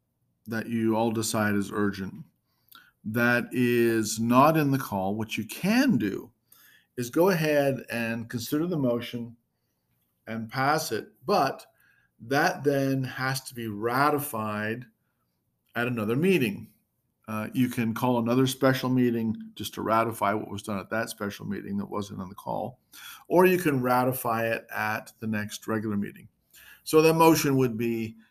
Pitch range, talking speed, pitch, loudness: 110-130 Hz, 155 wpm, 120 Hz, -26 LUFS